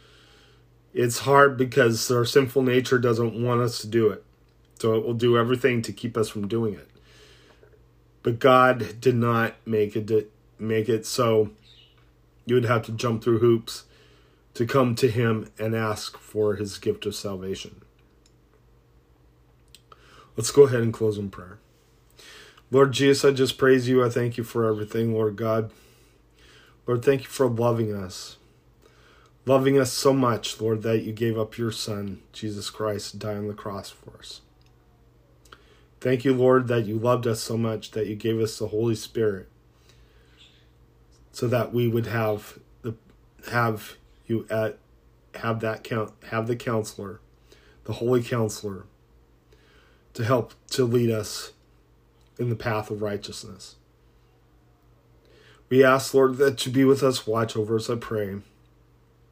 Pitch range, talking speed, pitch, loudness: 105-120 Hz, 155 wpm, 110 Hz, -24 LUFS